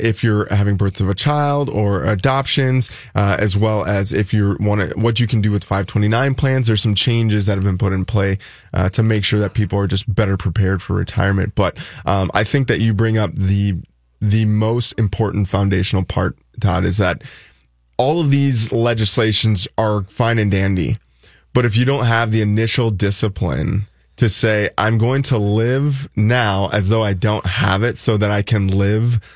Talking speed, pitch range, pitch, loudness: 195 wpm, 100-115 Hz, 105 Hz, -17 LUFS